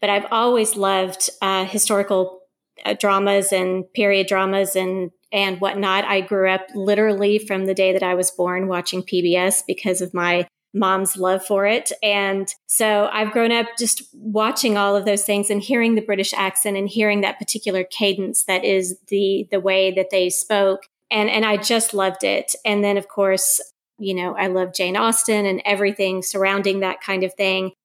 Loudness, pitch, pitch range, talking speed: -19 LUFS, 195 Hz, 190-210 Hz, 185 wpm